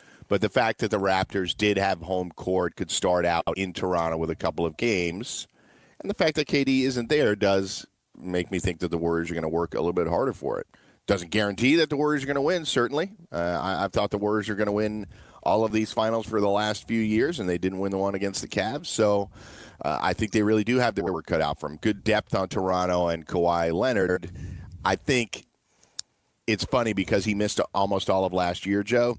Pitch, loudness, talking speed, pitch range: 100 Hz, -26 LUFS, 235 wpm, 90-110 Hz